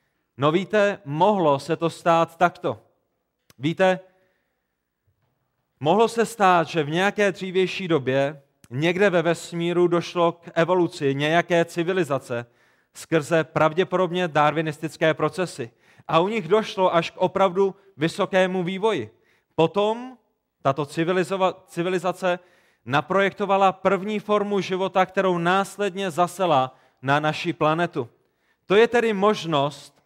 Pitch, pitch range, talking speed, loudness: 175 Hz, 155-190 Hz, 110 wpm, -22 LUFS